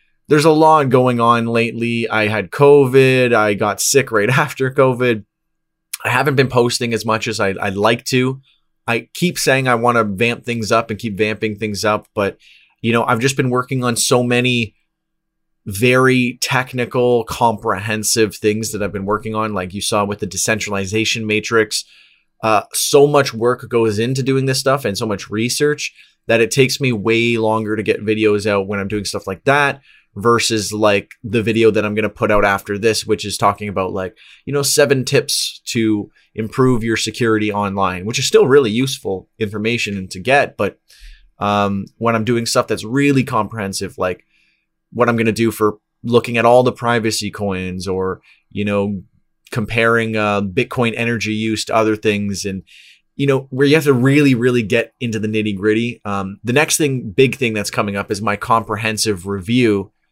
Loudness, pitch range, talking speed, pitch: -16 LUFS, 105-125 Hz, 190 wpm, 115 Hz